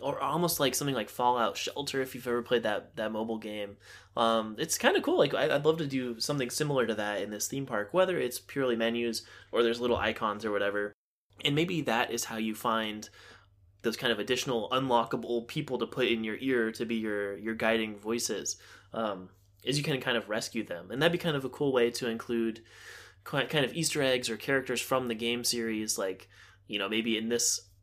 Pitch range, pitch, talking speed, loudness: 110-130 Hz, 115 Hz, 220 wpm, -30 LUFS